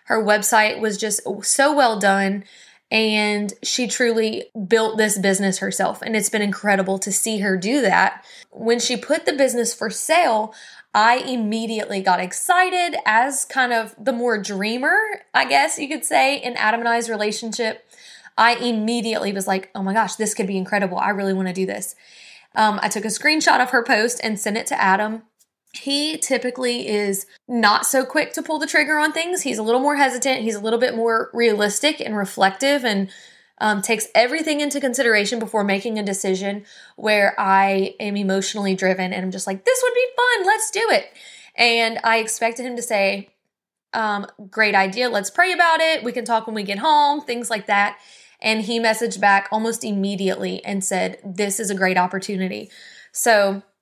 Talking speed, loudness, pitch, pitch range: 185 wpm, -19 LUFS, 220 Hz, 205-250 Hz